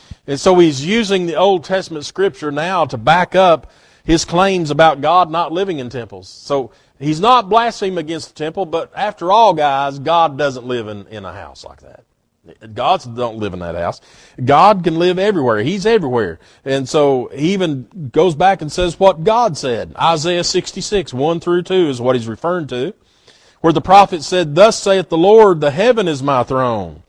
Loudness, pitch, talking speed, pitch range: -15 LUFS, 165 Hz, 190 wpm, 130-185 Hz